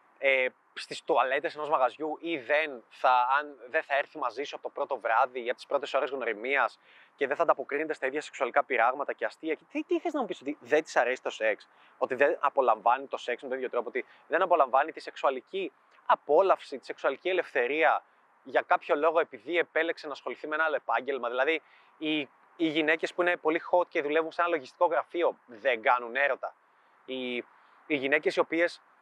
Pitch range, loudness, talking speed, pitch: 145-175 Hz, -29 LUFS, 205 wpm, 160 Hz